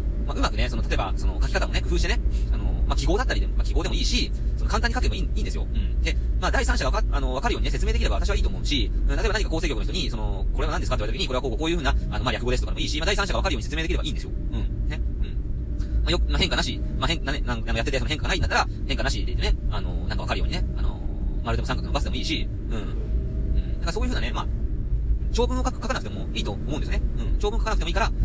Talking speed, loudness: 625 characters per minute, -26 LUFS